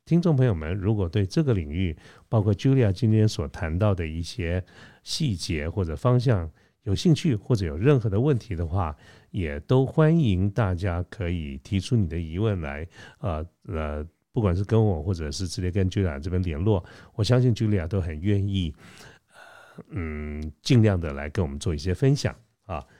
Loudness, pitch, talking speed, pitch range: -25 LUFS, 95 Hz, 285 characters per minute, 85-110 Hz